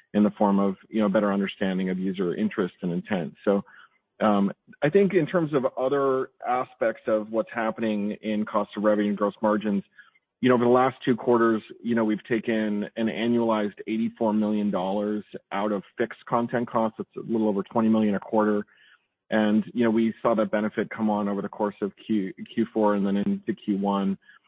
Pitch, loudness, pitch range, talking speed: 110 Hz, -25 LUFS, 105-115 Hz, 195 wpm